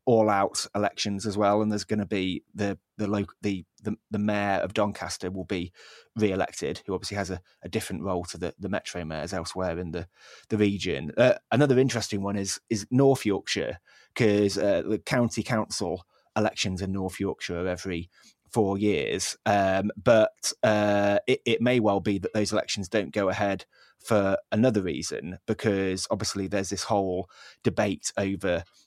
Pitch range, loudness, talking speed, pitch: 95-105 Hz, -27 LUFS, 180 wpm, 100 Hz